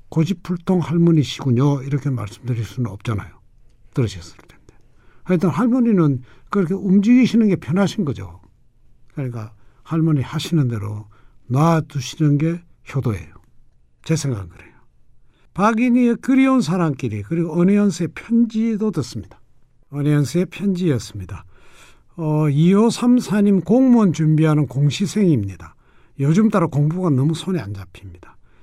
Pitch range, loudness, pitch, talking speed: 120-185 Hz, -19 LUFS, 150 Hz, 310 characters per minute